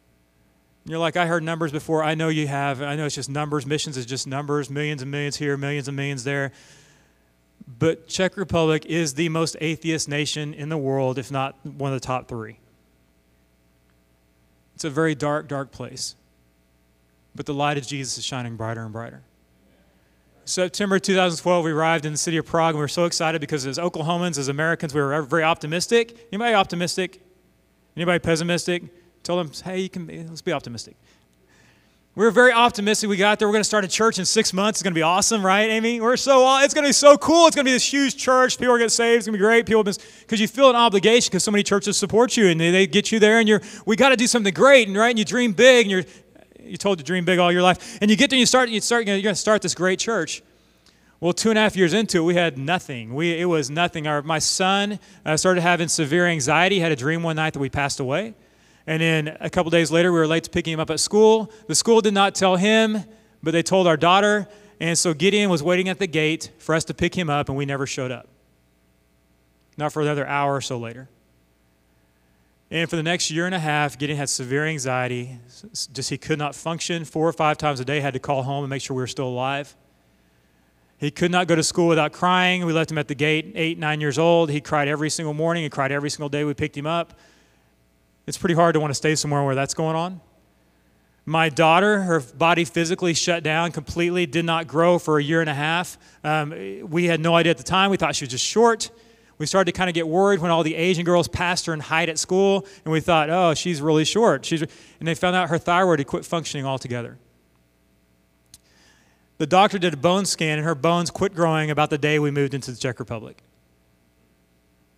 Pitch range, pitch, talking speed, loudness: 140-185 Hz, 160 Hz, 235 wpm, -20 LUFS